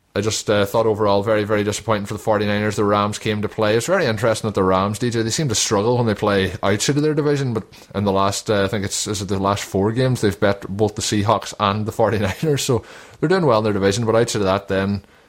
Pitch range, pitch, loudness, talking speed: 100-115 Hz, 105 Hz, -19 LUFS, 265 wpm